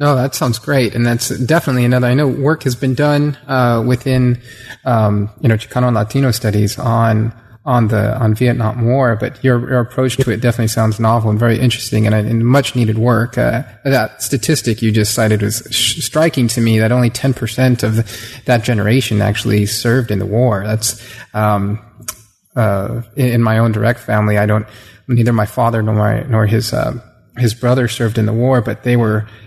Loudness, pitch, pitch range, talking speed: -15 LUFS, 115 Hz, 110-125 Hz, 200 wpm